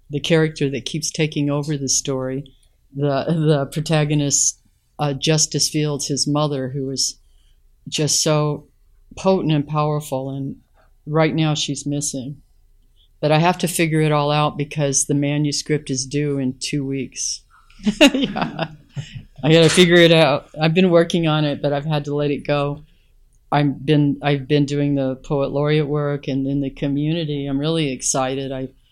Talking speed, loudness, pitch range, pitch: 165 wpm, -19 LUFS, 140-155 Hz, 145 Hz